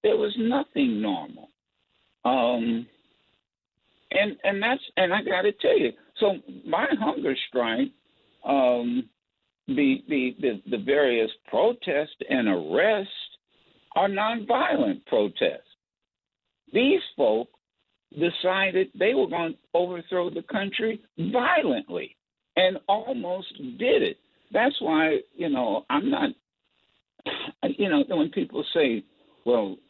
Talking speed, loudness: 110 wpm, -25 LUFS